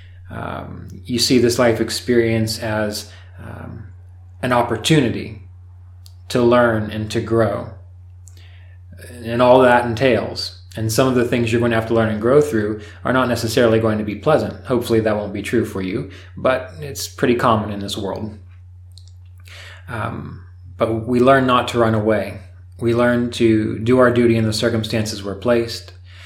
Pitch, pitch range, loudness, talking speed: 110 Hz, 90-120 Hz, -18 LUFS, 165 wpm